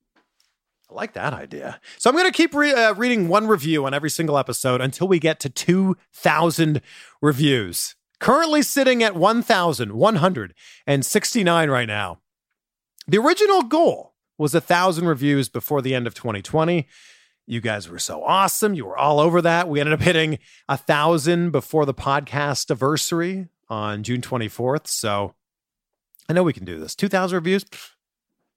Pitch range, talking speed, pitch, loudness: 130-185 Hz, 150 wpm, 155 Hz, -20 LUFS